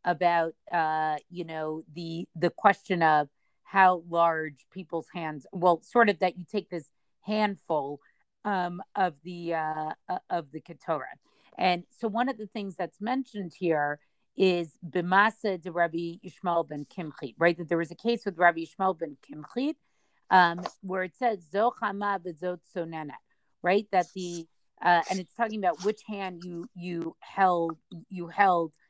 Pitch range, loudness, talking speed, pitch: 165-195 Hz, -28 LUFS, 150 wpm, 175 Hz